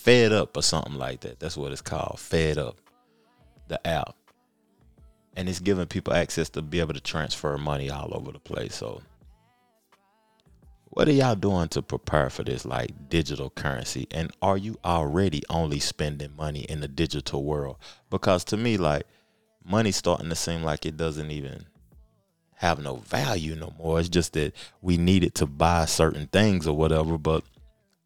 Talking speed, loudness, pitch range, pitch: 175 wpm, -27 LUFS, 75-95 Hz, 80 Hz